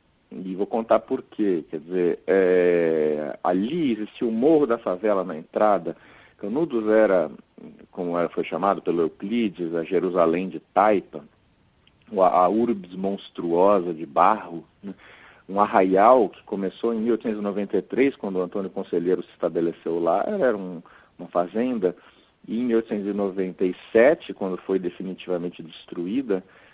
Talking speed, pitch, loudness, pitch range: 130 wpm, 95 Hz, -23 LUFS, 90-110 Hz